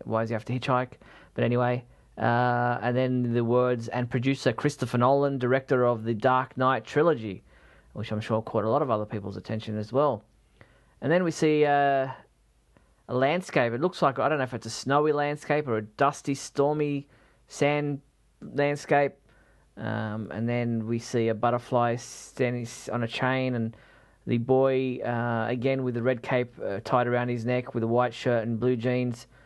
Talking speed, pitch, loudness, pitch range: 185 wpm, 125 Hz, -27 LUFS, 115-135 Hz